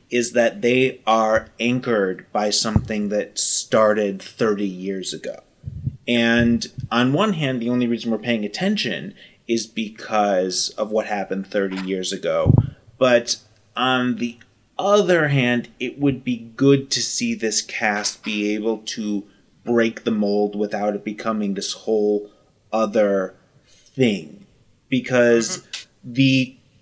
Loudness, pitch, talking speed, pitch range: -21 LUFS, 115 Hz, 130 wpm, 105-125 Hz